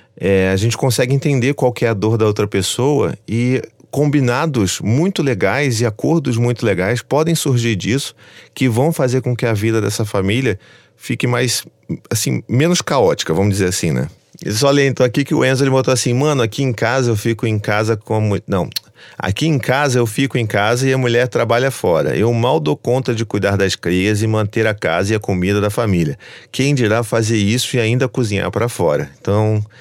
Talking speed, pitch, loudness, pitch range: 210 wpm, 120 Hz, -16 LUFS, 105-130 Hz